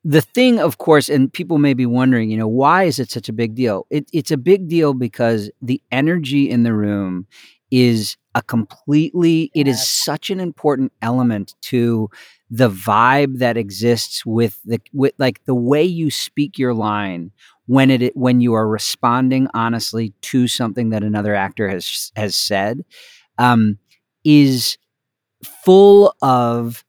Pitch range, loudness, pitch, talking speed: 115-145 Hz, -16 LUFS, 125 Hz, 160 wpm